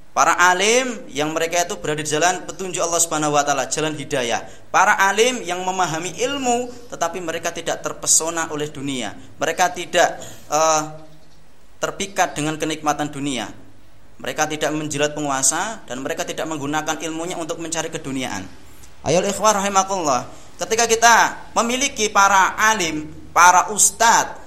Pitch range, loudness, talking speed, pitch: 150-190 Hz, -19 LUFS, 135 wpm, 160 Hz